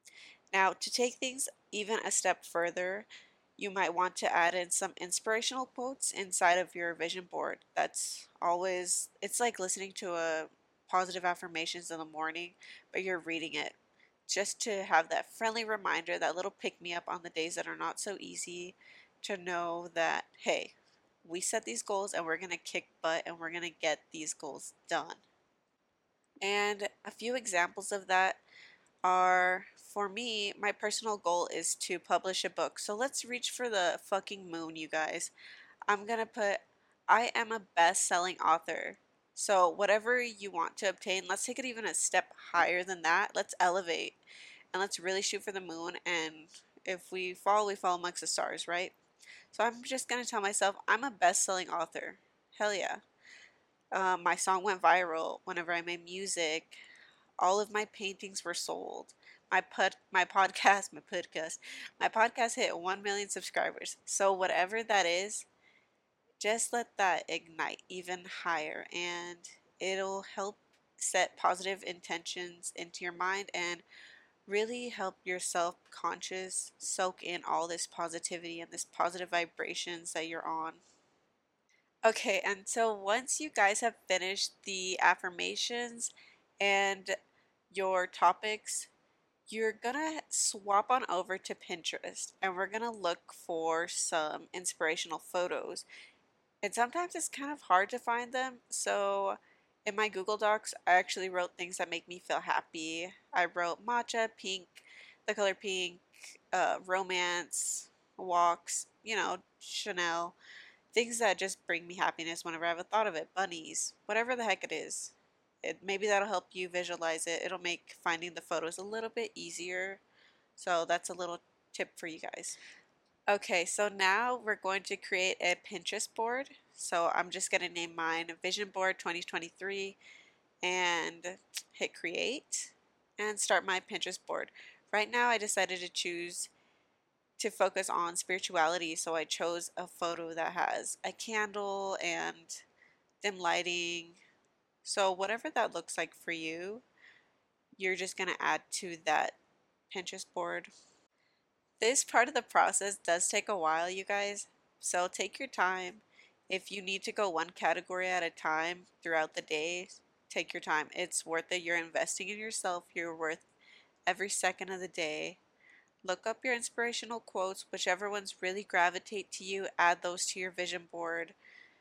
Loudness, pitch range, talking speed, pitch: -34 LUFS, 175-205 Hz, 160 wpm, 185 Hz